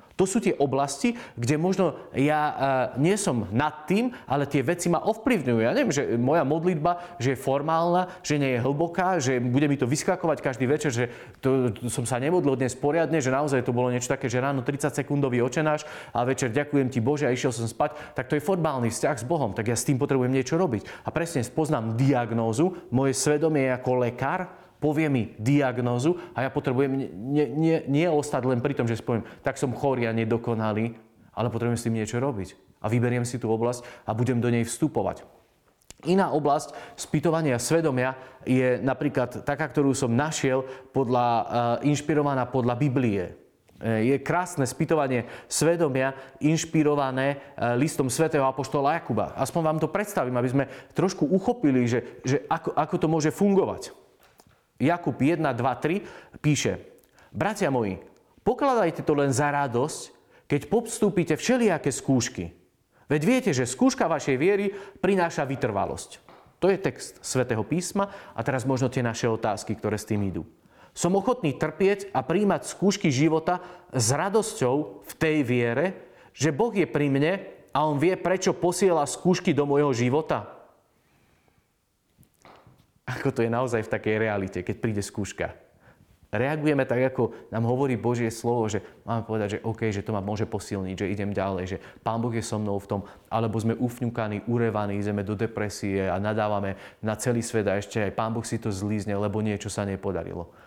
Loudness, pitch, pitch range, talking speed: -26 LUFS, 135 Hz, 115-155 Hz, 170 wpm